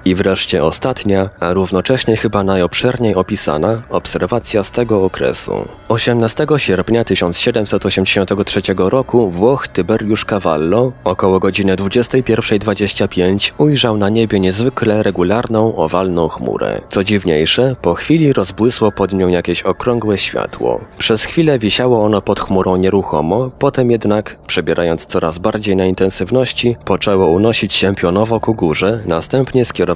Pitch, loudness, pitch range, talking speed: 105 Hz, -14 LUFS, 95-115 Hz, 120 wpm